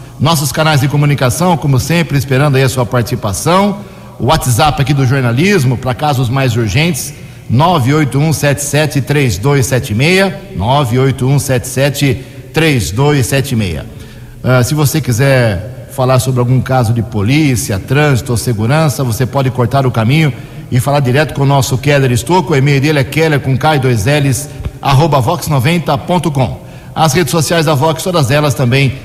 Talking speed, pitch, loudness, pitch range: 130 wpm, 135 Hz, -12 LUFS, 125-150 Hz